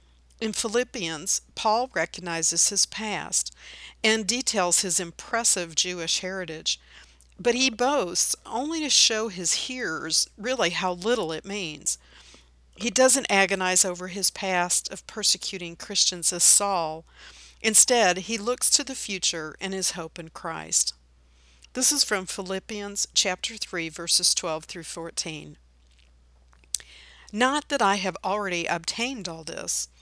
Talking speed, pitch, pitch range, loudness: 130 wpm, 185 Hz, 160-220 Hz, -24 LUFS